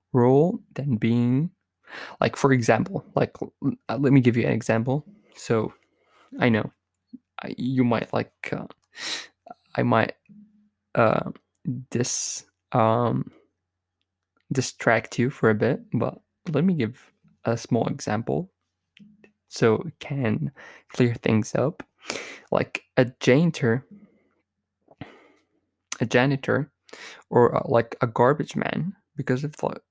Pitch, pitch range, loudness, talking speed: 130 Hz, 115-155 Hz, -24 LUFS, 120 wpm